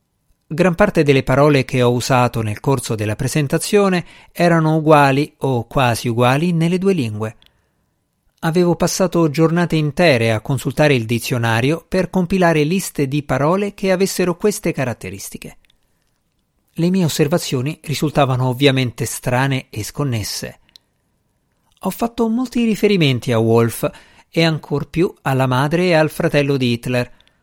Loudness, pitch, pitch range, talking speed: -17 LUFS, 150 Hz, 130-175 Hz, 130 wpm